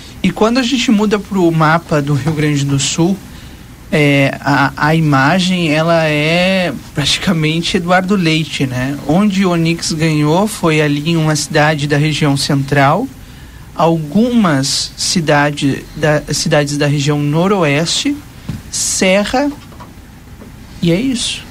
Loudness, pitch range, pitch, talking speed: -13 LUFS, 145-185 Hz, 160 Hz, 125 wpm